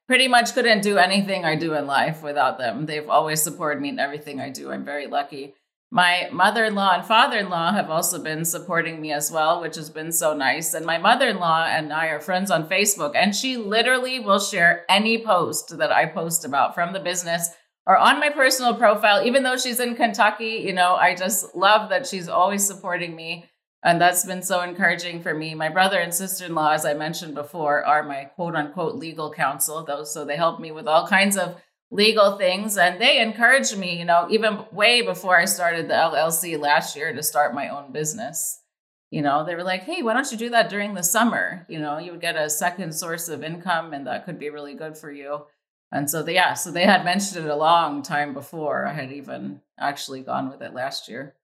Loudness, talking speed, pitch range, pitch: -21 LUFS, 225 wpm, 155-200 Hz, 175 Hz